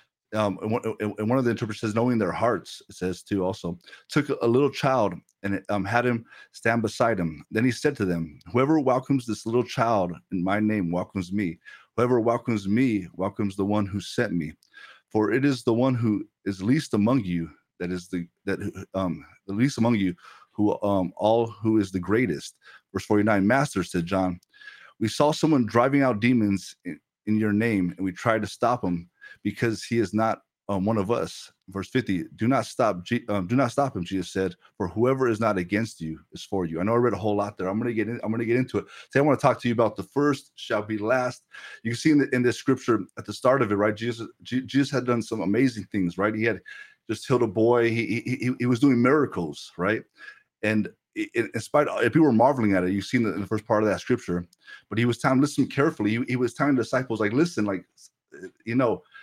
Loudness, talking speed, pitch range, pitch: -25 LUFS, 230 wpm, 95-120 Hz, 110 Hz